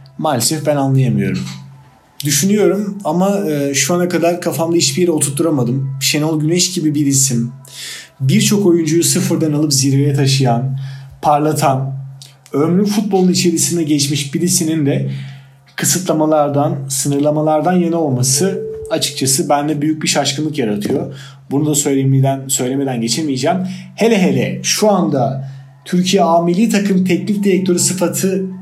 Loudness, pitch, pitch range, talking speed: -15 LUFS, 150 Hz, 135-175 Hz, 115 wpm